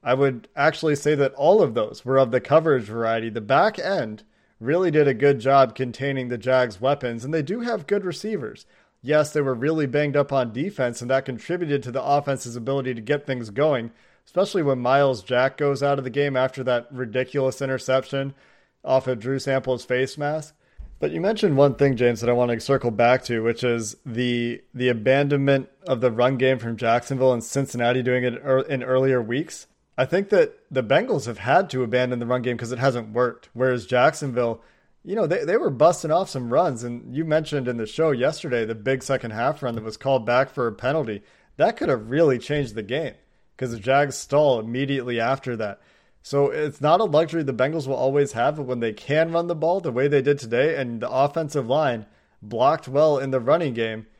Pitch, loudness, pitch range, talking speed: 130 Hz, -22 LUFS, 120-145 Hz, 215 wpm